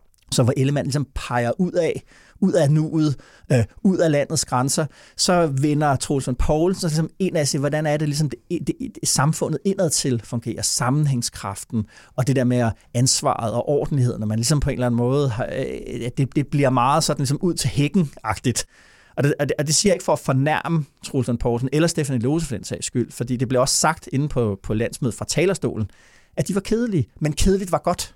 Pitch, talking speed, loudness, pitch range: 140 Hz, 200 wpm, -21 LUFS, 125-155 Hz